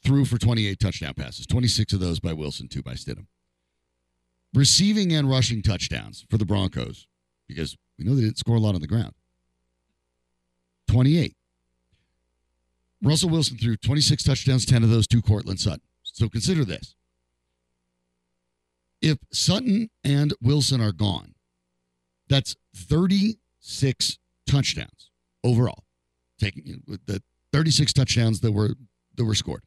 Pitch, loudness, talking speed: 105 Hz, -23 LUFS, 135 wpm